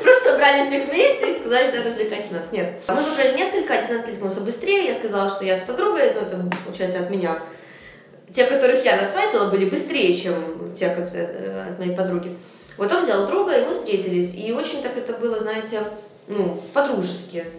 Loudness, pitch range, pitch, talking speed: -21 LUFS, 180-280 Hz, 215 Hz, 185 wpm